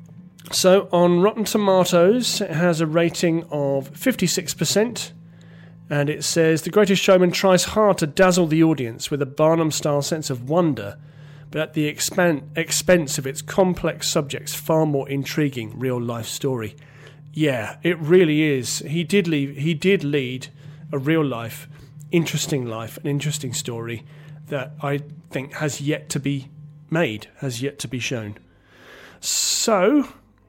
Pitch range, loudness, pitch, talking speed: 140-170 Hz, -21 LUFS, 150 Hz, 150 wpm